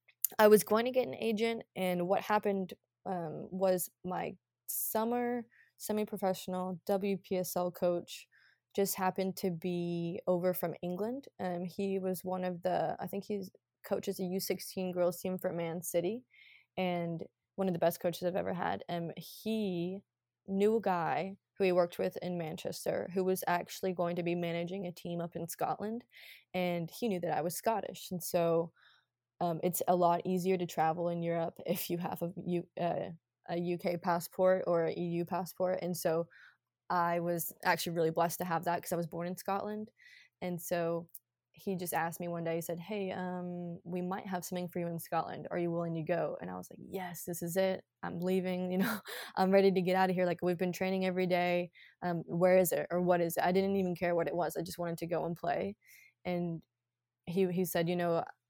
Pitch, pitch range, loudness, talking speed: 180 Hz, 170-190 Hz, -34 LUFS, 210 wpm